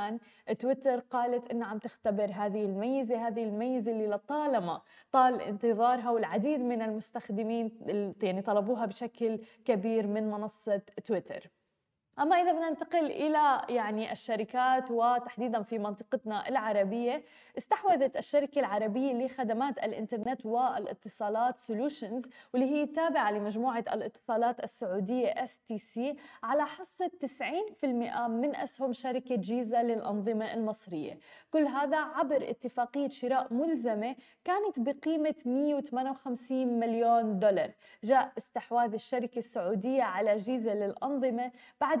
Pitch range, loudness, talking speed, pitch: 220-270 Hz, -32 LUFS, 110 wpm, 245 Hz